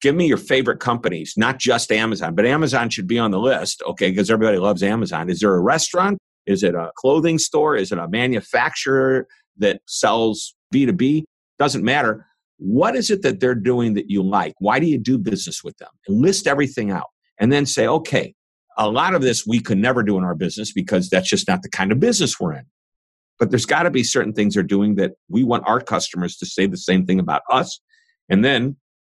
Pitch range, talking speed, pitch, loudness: 100-135 Hz, 215 wpm, 110 Hz, -19 LUFS